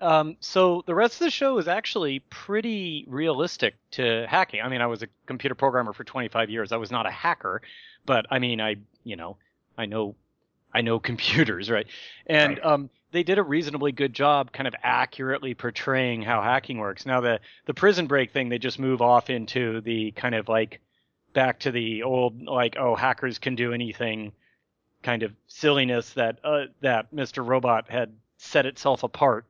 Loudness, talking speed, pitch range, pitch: -25 LUFS, 185 wpm, 115-145 Hz, 130 Hz